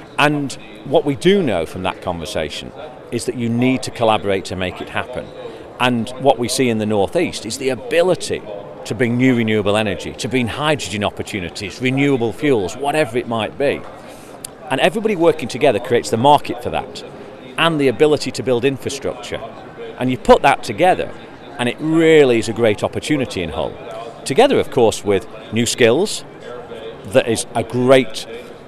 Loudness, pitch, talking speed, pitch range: -17 LUFS, 125 Hz, 170 wpm, 110-140 Hz